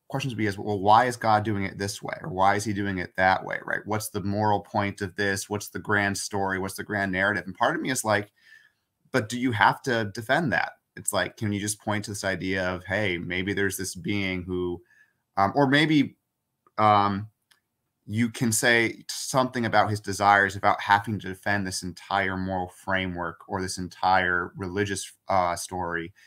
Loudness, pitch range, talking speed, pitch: -26 LUFS, 95-105 Hz, 205 wpm, 100 Hz